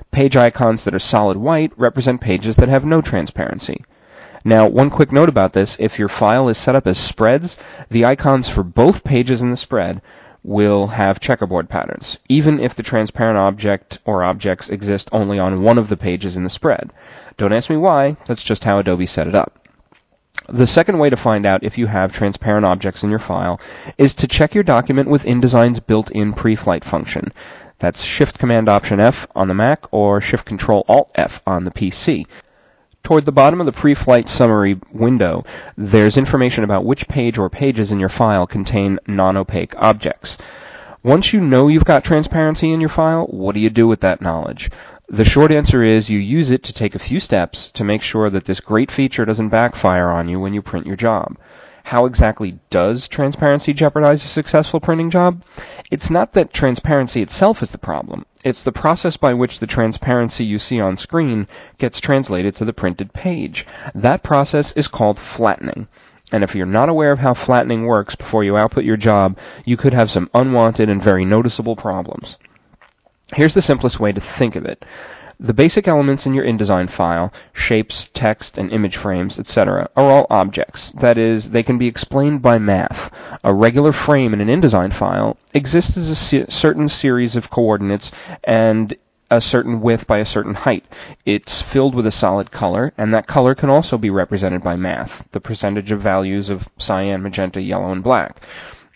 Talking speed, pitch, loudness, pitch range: 190 wpm, 115 Hz, -15 LUFS, 100-135 Hz